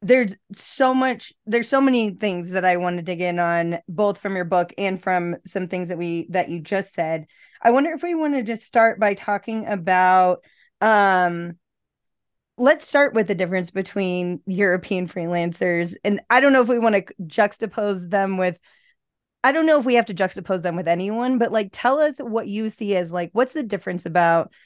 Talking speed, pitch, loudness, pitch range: 200 wpm, 195 Hz, -21 LUFS, 180-230 Hz